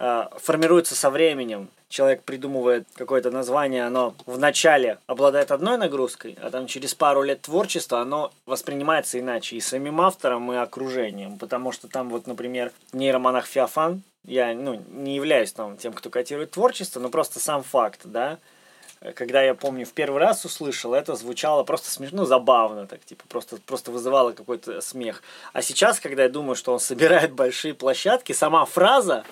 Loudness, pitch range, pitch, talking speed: -23 LUFS, 125-150 Hz, 130 Hz, 165 wpm